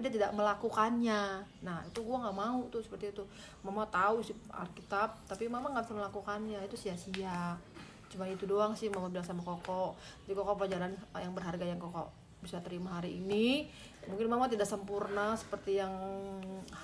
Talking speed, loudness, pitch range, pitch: 170 wpm, -37 LUFS, 185-215 Hz, 200 Hz